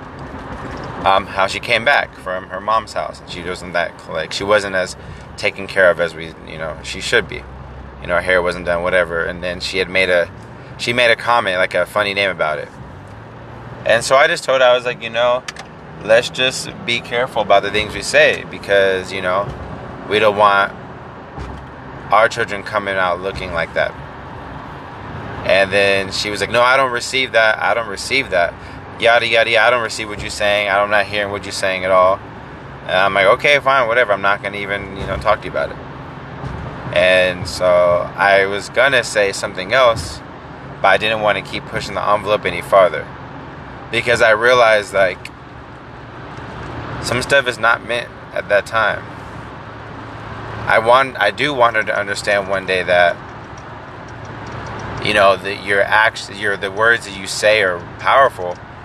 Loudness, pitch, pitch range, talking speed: -16 LUFS, 100 Hz, 95-115 Hz, 190 wpm